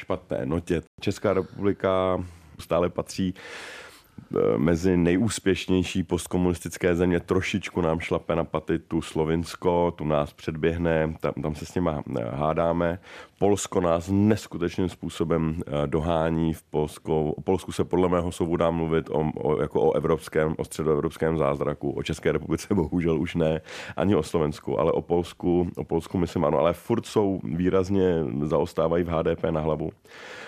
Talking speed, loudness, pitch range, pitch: 145 wpm, -26 LUFS, 80-90 Hz, 85 Hz